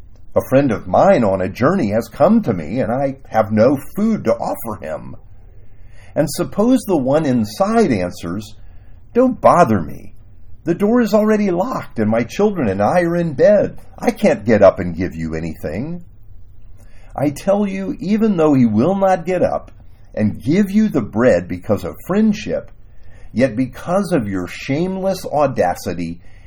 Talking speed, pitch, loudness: 165 wpm, 120 Hz, -17 LUFS